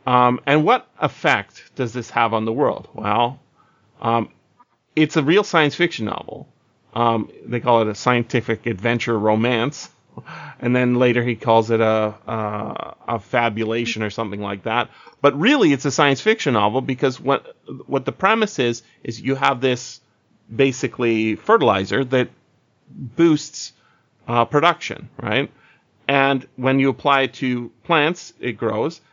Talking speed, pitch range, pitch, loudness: 150 wpm, 115-140 Hz, 125 Hz, -20 LUFS